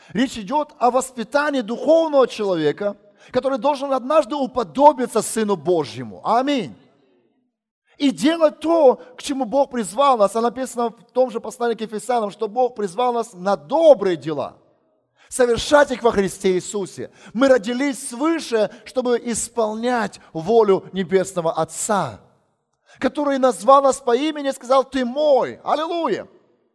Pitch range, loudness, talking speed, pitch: 210-275 Hz, -20 LUFS, 130 wpm, 240 Hz